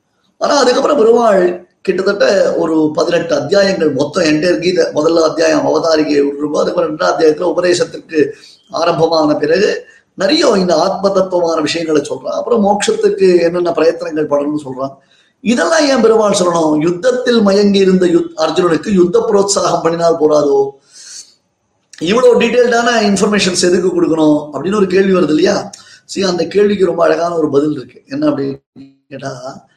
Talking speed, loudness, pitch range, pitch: 135 wpm, -12 LUFS, 155-205 Hz, 175 Hz